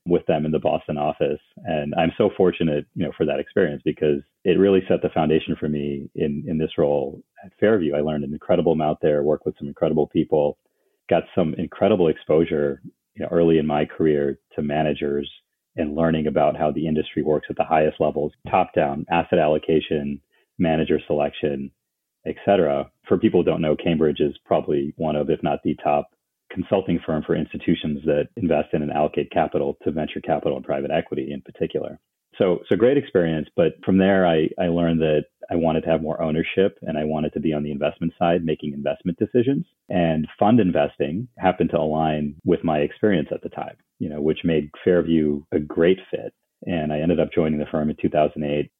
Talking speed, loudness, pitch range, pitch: 200 wpm, -22 LUFS, 75-80 Hz, 75 Hz